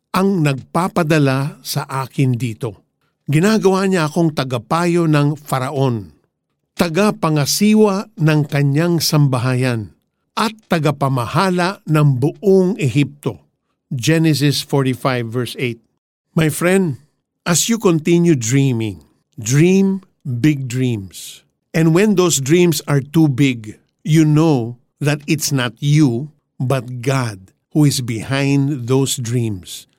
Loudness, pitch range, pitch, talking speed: -16 LUFS, 130-170 Hz, 145 Hz, 105 wpm